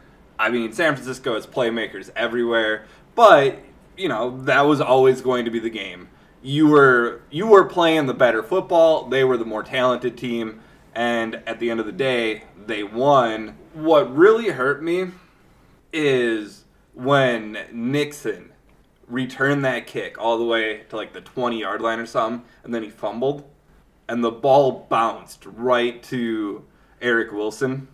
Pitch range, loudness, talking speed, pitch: 115-135 Hz, -20 LUFS, 160 wpm, 120 Hz